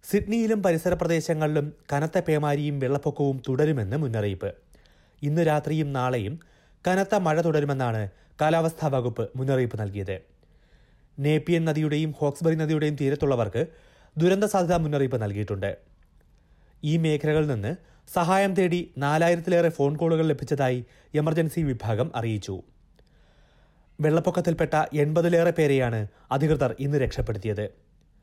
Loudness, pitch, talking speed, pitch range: -25 LUFS, 150 Hz, 95 wpm, 125-165 Hz